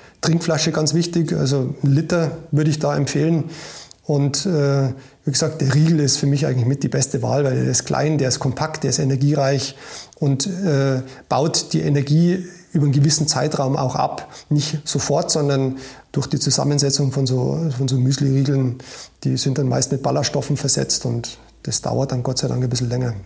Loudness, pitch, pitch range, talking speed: -19 LUFS, 140 Hz, 135-155 Hz, 190 wpm